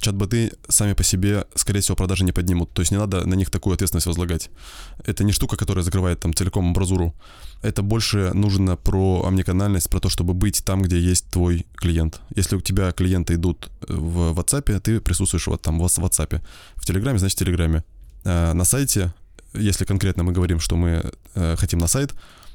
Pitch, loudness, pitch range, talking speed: 95 Hz, -21 LUFS, 85-100 Hz, 185 wpm